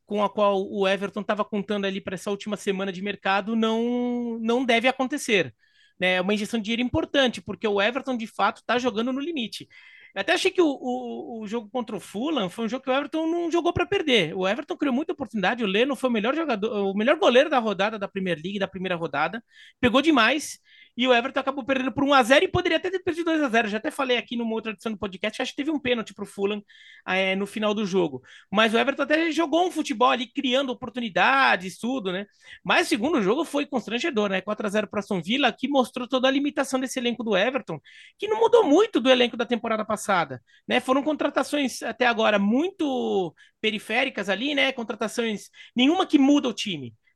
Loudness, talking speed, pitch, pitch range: -24 LUFS, 220 wpm, 240 Hz, 210-275 Hz